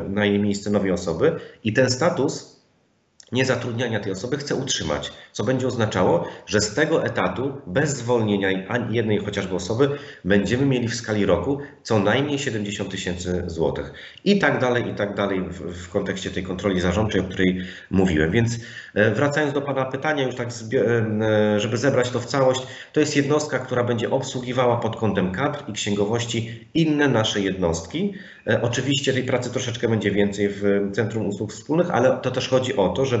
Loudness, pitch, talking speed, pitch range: -22 LUFS, 115 Hz, 170 wpm, 100-130 Hz